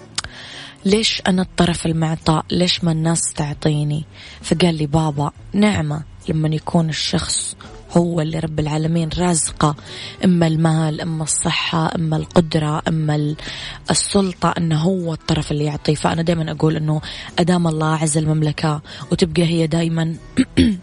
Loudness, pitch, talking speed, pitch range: -19 LUFS, 160 Hz, 125 wpm, 150-170 Hz